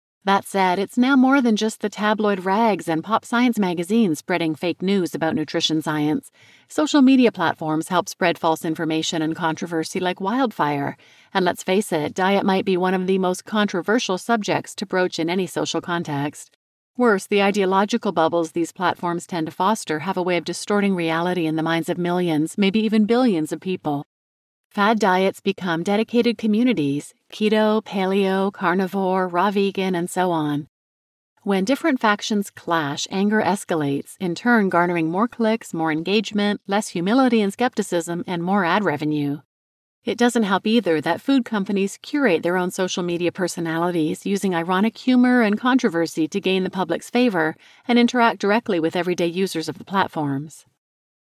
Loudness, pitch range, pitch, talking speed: -21 LUFS, 165-215 Hz, 185 Hz, 165 wpm